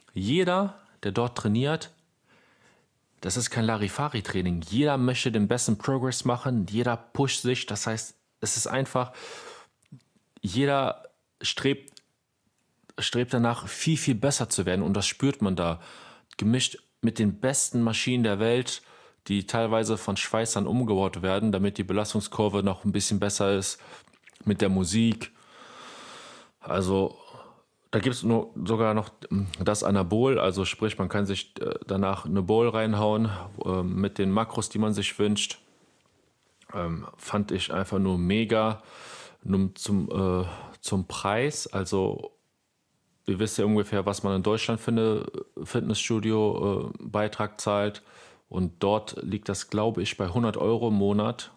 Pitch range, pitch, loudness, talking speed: 100-120 Hz, 110 Hz, -27 LUFS, 140 wpm